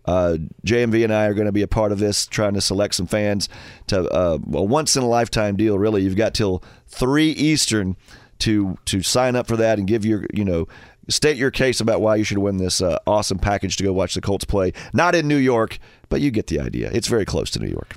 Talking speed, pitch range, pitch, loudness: 240 wpm, 95-115 Hz, 105 Hz, -20 LUFS